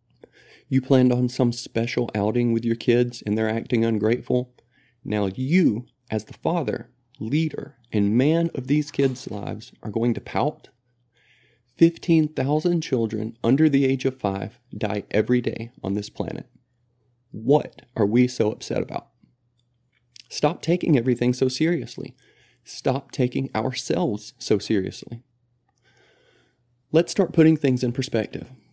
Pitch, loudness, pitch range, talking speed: 125 Hz, -23 LUFS, 115-135 Hz, 135 wpm